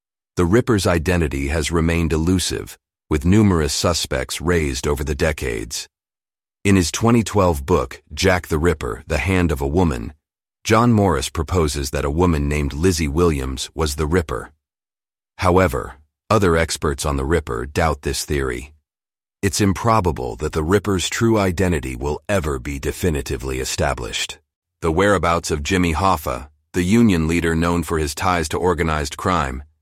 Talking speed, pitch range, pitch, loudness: 145 wpm, 75-95 Hz, 85 Hz, -19 LUFS